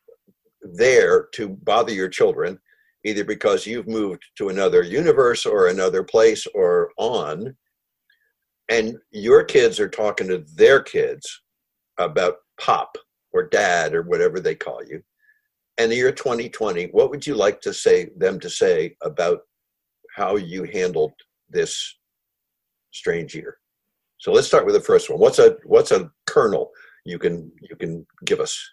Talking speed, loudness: 150 wpm, -20 LUFS